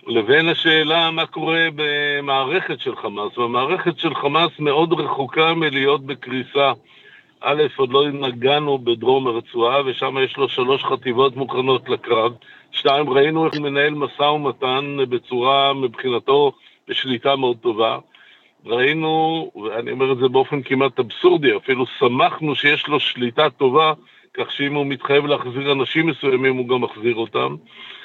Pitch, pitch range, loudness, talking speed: 145 Hz, 135-160 Hz, -19 LUFS, 135 wpm